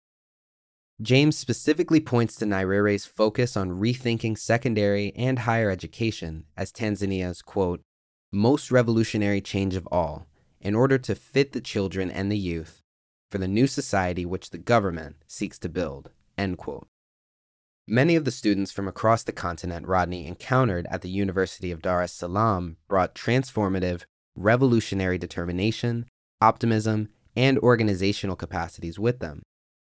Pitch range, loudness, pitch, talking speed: 90-115 Hz, -25 LUFS, 100 Hz, 135 wpm